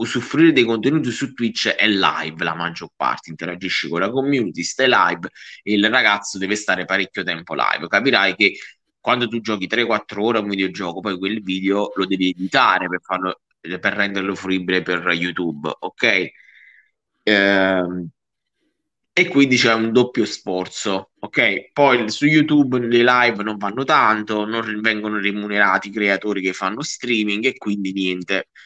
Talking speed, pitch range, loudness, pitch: 155 wpm, 95-115 Hz, -19 LUFS, 100 Hz